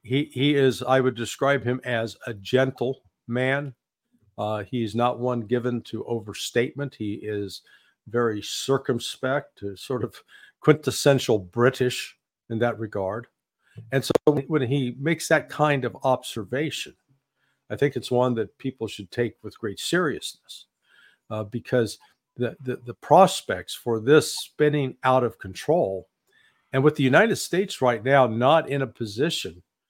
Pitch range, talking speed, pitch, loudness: 115-135 Hz, 145 wpm, 125 Hz, -24 LUFS